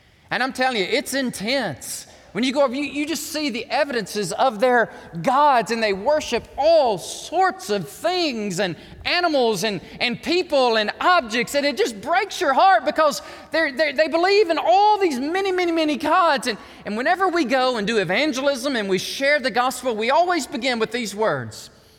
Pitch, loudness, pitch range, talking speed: 275 Hz, -20 LUFS, 225-320 Hz, 190 wpm